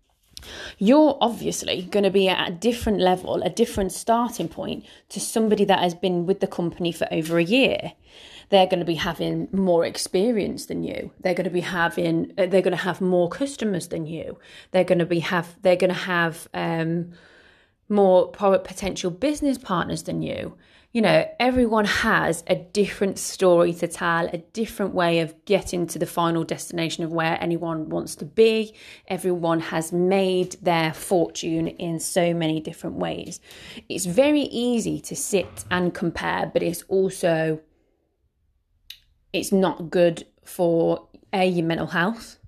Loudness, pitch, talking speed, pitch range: -23 LUFS, 180 Hz, 160 wpm, 170-195 Hz